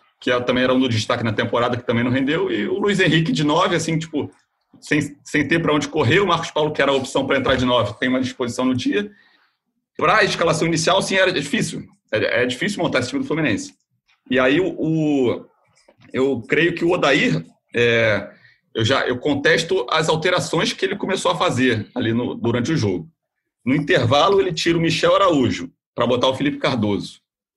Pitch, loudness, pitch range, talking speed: 140 Hz, -19 LUFS, 125-170 Hz, 205 wpm